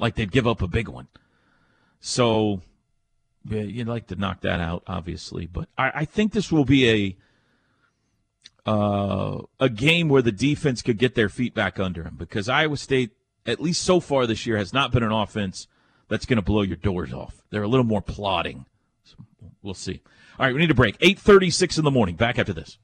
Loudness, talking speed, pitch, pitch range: -23 LUFS, 210 wpm, 115 Hz, 100-135 Hz